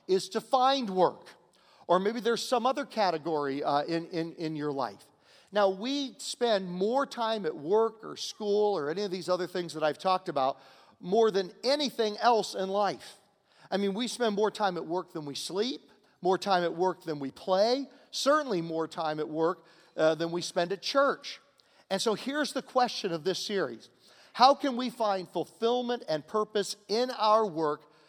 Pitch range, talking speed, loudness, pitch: 170-235 Hz, 190 wpm, -30 LUFS, 200 Hz